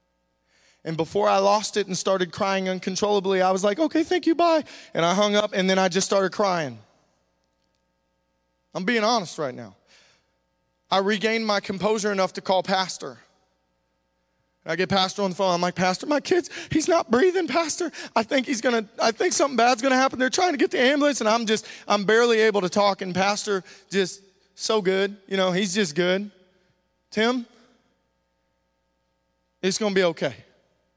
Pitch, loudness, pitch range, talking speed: 195 Hz, -23 LUFS, 170-225 Hz, 180 wpm